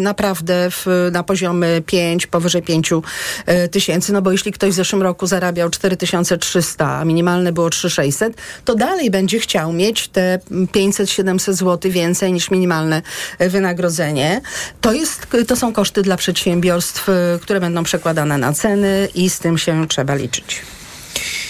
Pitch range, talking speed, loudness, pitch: 170-195 Hz, 140 wpm, -16 LUFS, 180 Hz